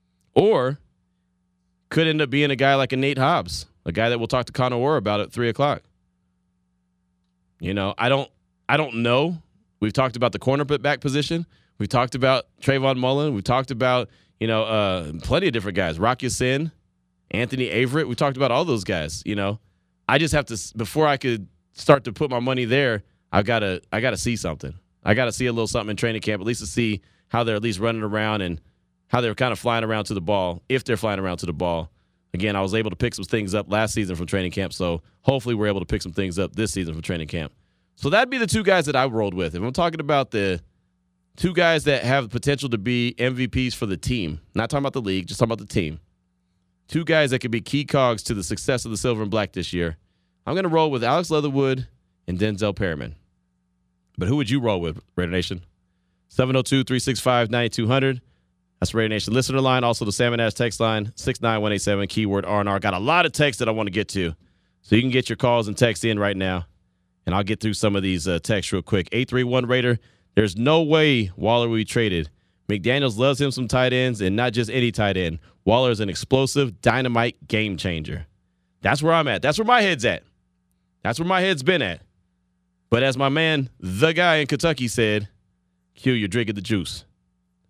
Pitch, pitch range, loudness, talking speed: 110 Hz, 90-130 Hz, -22 LUFS, 225 wpm